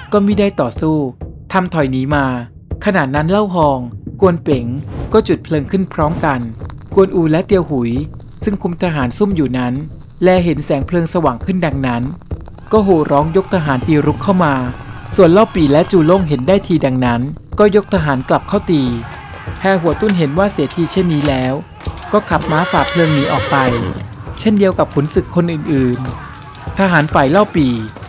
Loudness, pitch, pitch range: -14 LUFS, 155 Hz, 135-185 Hz